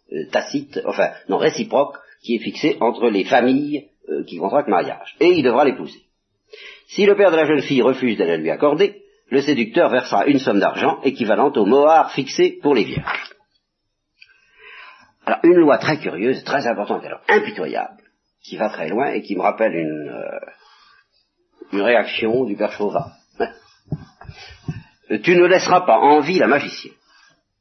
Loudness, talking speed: -18 LUFS, 160 wpm